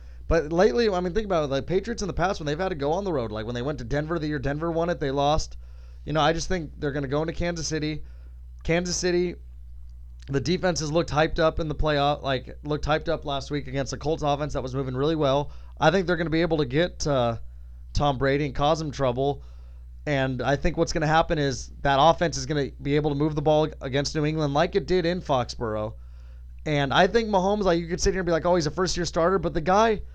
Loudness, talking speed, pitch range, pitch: -25 LUFS, 270 wpm, 135-170 Hz, 150 Hz